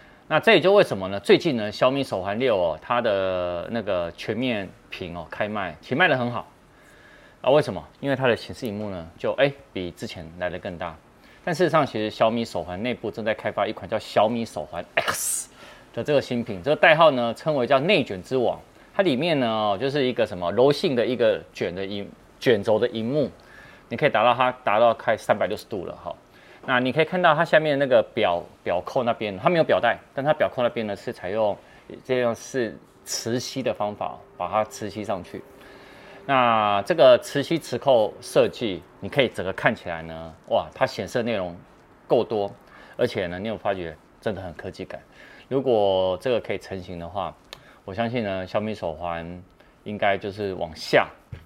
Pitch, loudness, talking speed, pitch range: 105 Hz, -23 LUFS, 285 characters per minute, 90-125 Hz